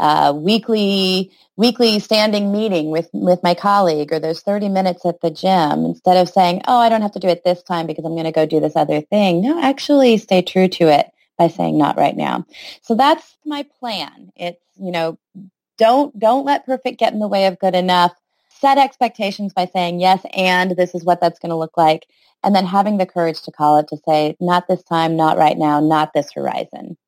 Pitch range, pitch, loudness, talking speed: 165-210 Hz, 185 Hz, -16 LUFS, 220 wpm